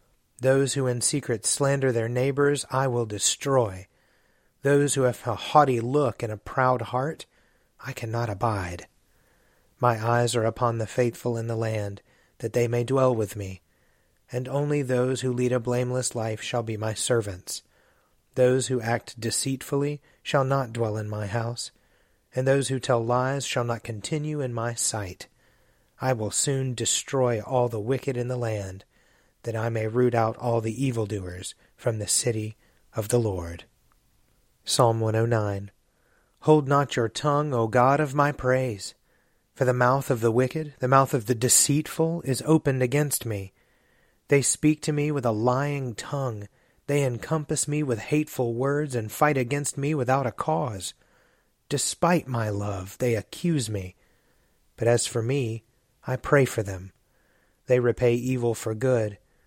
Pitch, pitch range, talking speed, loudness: 125 Hz, 115-135 Hz, 160 wpm, -25 LUFS